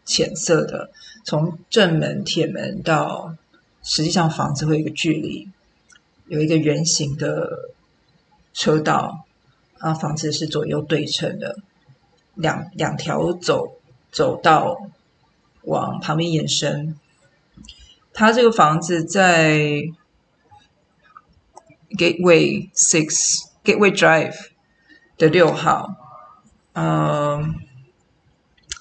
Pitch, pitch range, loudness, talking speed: 160 Hz, 155-190 Hz, -19 LUFS, 170 characters per minute